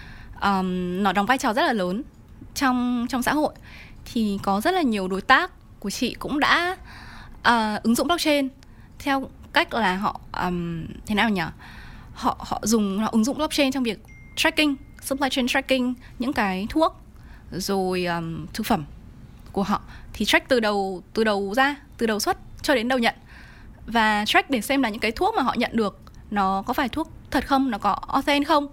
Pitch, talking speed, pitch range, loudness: 235 Hz, 195 wpm, 200-275 Hz, -23 LUFS